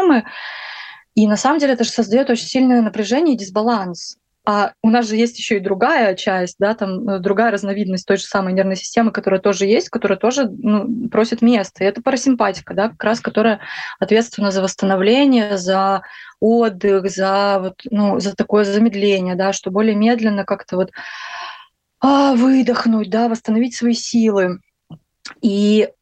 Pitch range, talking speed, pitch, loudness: 195-235 Hz, 155 wpm, 215 Hz, -17 LUFS